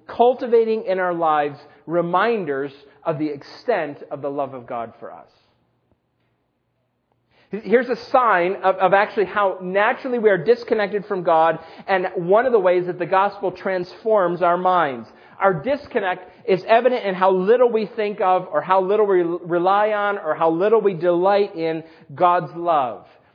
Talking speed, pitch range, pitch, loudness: 160 wpm, 170-205 Hz, 185 Hz, -20 LUFS